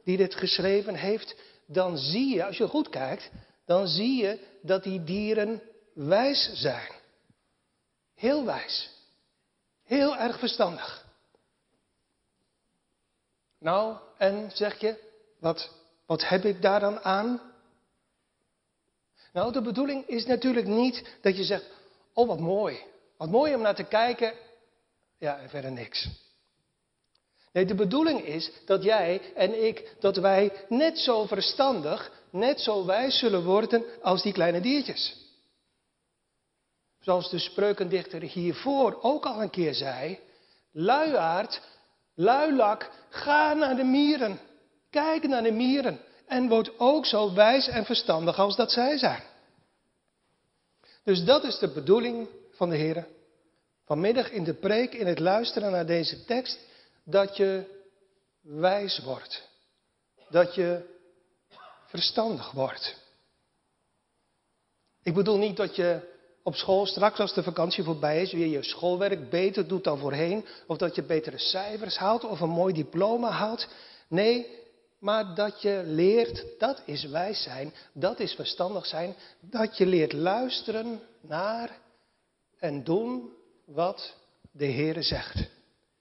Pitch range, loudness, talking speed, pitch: 180-235 Hz, -27 LUFS, 135 wpm, 200 Hz